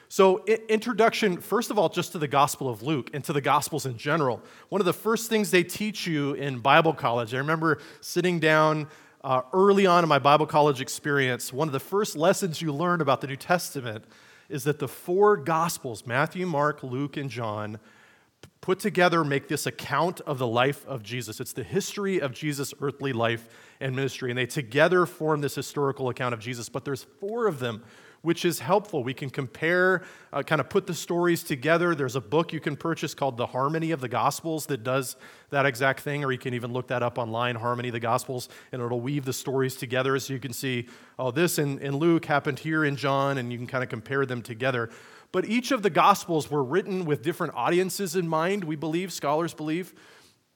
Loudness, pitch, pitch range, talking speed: -26 LUFS, 145 Hz, 130-170 Hz, 210 wpm